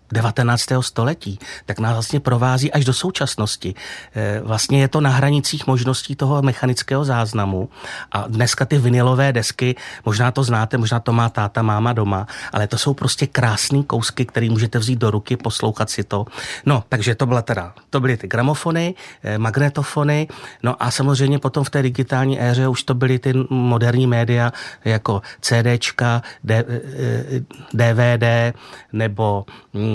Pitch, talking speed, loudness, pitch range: 125 Hz, 150 wpm, -19 LUFS, 115-135 Hz